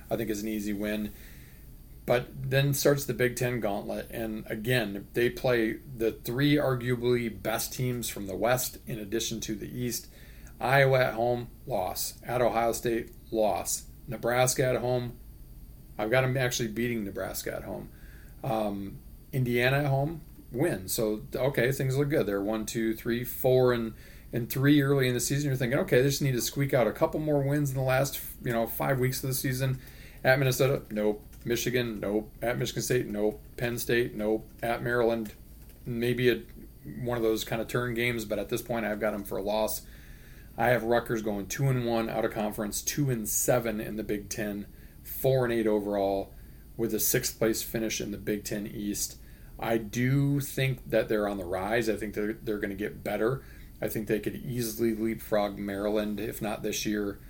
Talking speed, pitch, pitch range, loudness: 195 wpm, 115 Hz, 110-125 Hz, -29 LUFS